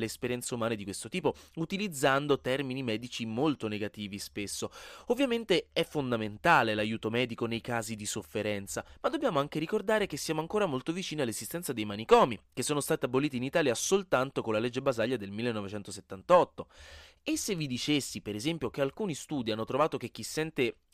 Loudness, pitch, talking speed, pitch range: -31 LUFS, 130 Hz, 170 wpm, 110-155 Hz